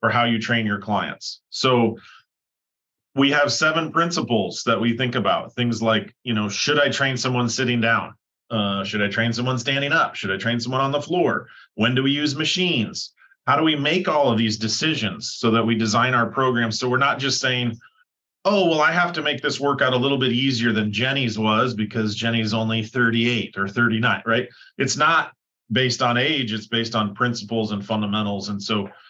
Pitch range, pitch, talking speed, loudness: 110-135 Hz, 120 Hz, 200 wpm, -21 LUFS